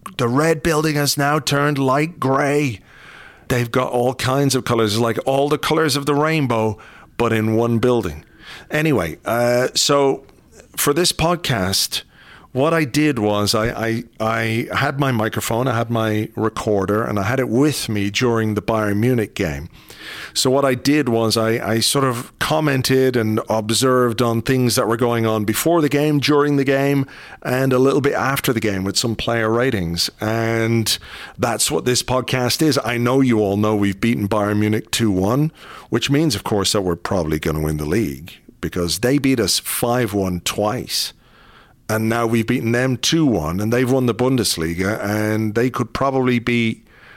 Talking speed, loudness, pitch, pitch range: 185 wpm, -18 LUFS, 120 Hz, 110-135 Hz